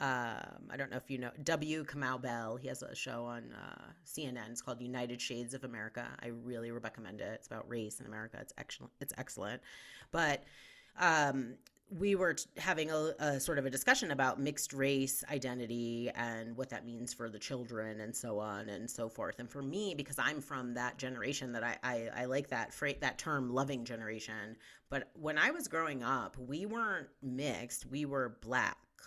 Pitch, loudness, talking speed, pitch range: 125 Hz, -38 LUFS, 200 wpm, 120-140 Hz